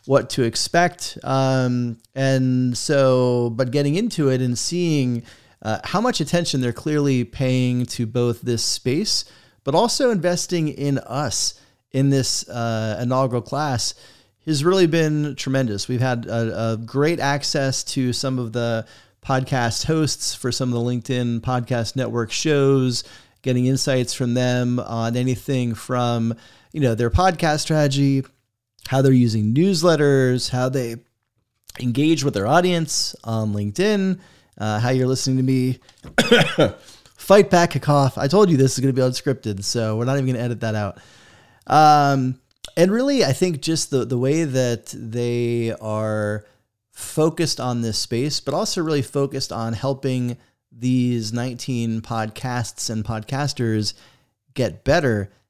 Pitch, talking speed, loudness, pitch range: 130 Hz, 150 wpm, -20 LUFS, 115-140 Hz